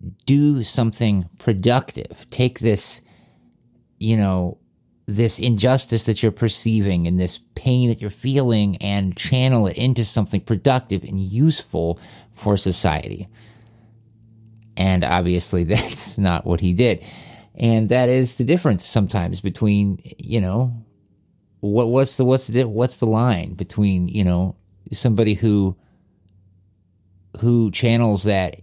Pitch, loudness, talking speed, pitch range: 105 Hz, -19 LUFS, 125 wpm, 95-120 Hz